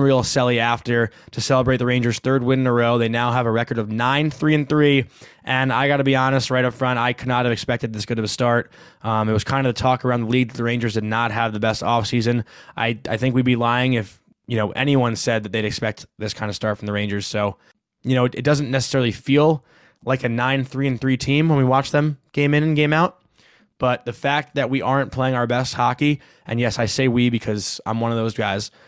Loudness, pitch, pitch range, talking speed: -20 LUFS, 125 Hz, 115-135 Hz, 260 wpm